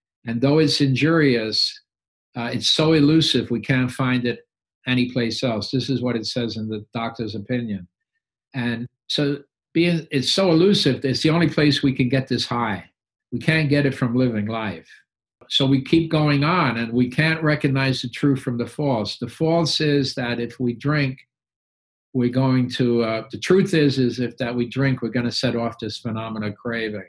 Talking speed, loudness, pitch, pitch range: 195 wpm, -21 LUFS, 125 Hz, 115-145 Hz